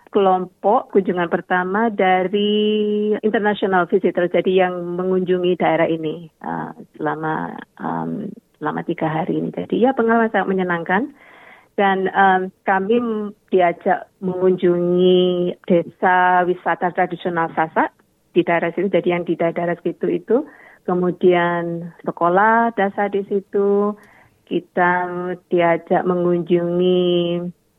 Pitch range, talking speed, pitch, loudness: 175-200 Hz, 105 wpm, 180 Hz, -19 LUFS